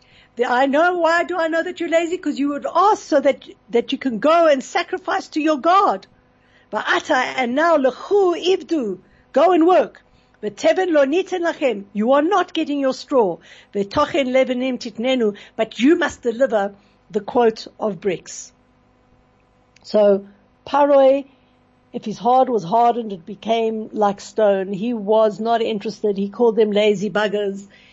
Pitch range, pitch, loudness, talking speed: 220-320 Hz, 260 Hz, -19 LUFS, 145 wpm